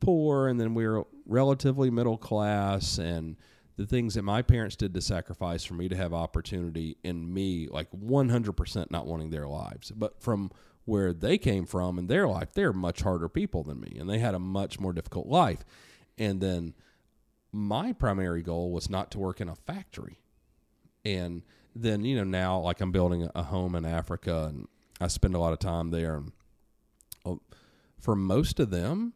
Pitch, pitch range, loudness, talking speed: 95 Hz, 85-110 Hz, -30 LUFS, 190 wpm